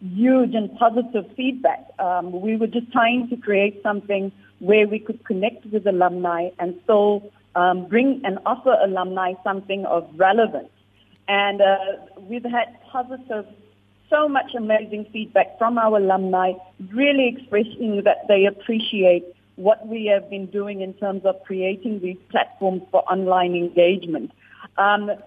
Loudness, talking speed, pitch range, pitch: -21 LUFS, 140 wpm, 190-225 Hz, 205 Hz